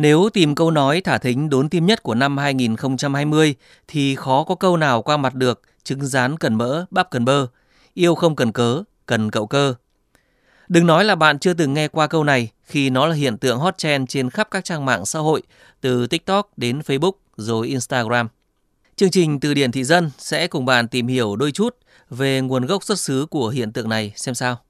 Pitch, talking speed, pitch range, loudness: 140 Hz, 215 wpm, 125-165 Hz, -19 LUFS